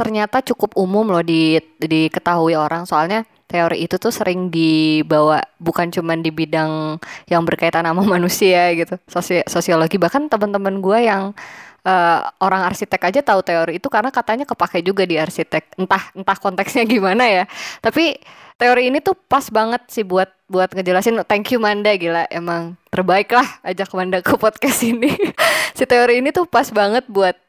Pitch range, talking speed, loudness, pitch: 170-225 Hz, 165 wpm, -17 LUFS, 190 Hz